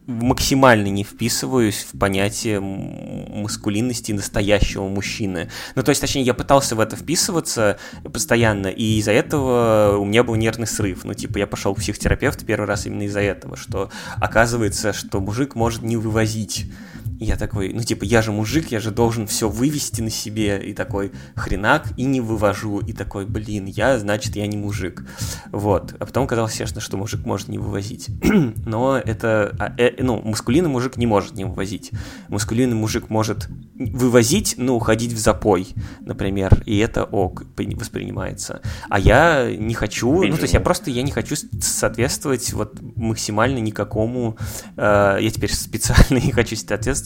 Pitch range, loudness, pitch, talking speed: 105-120 Hz, -20 LUFS, 110 Hz, 165 wpm